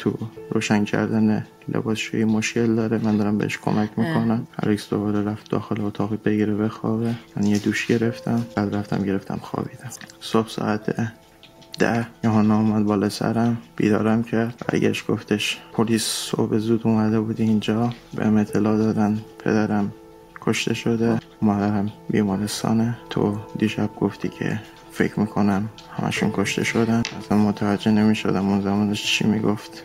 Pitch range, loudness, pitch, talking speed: 105-110 Hz, -22 LUFS, 110 Hz, 140 wpm